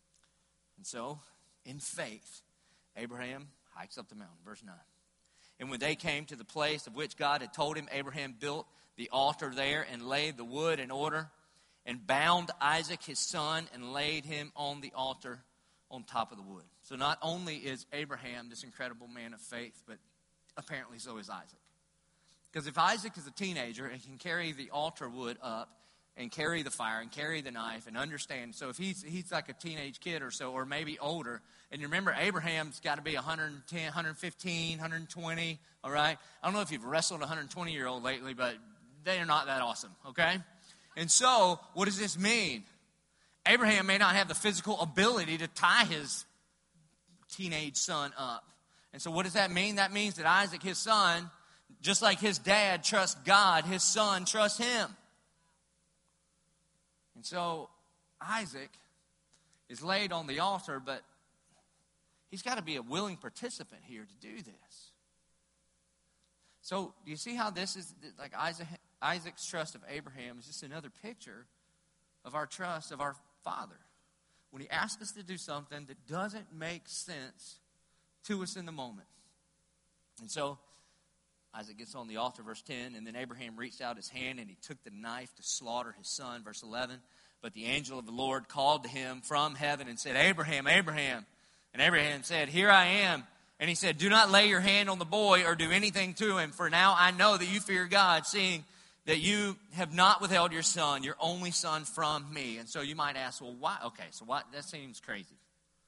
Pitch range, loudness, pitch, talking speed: 140-185 Hz, -32 LUFS, 165 Hz, 185 wpm